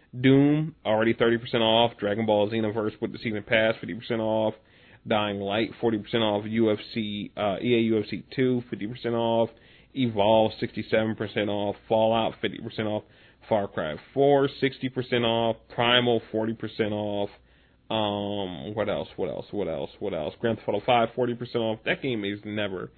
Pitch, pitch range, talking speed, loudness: 110 Hz, 105-120 Hz, 150 wpm, -26 LUFS